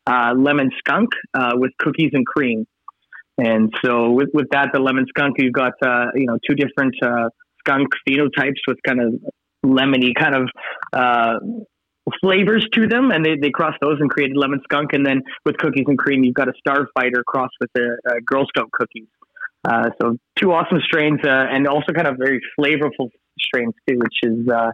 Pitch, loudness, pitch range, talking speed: 135 Hz, -18 LUFS, 125-145 Hz, 190 wpm